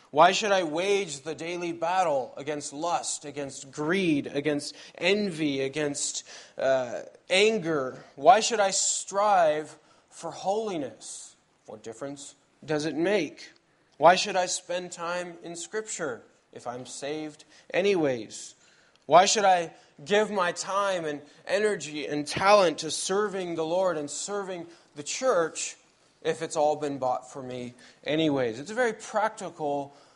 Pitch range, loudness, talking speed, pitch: 150-195 Hz, -27 LUFS, 135 wpm, 165 Hz